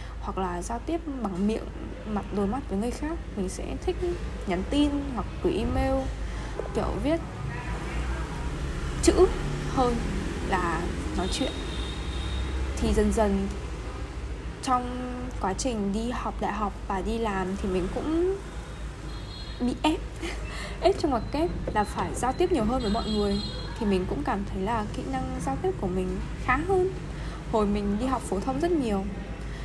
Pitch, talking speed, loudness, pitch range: 225 Hz, 160 wpm, -29 LUFS, 195-285 Hz